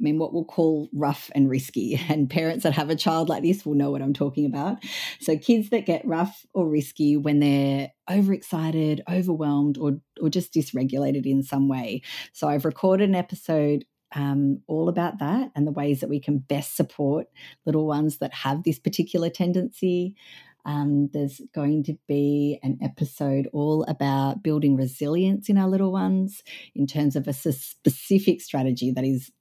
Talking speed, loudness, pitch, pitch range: 180 wpm, -24 LUFS, 150 Hz, 140-170 Hz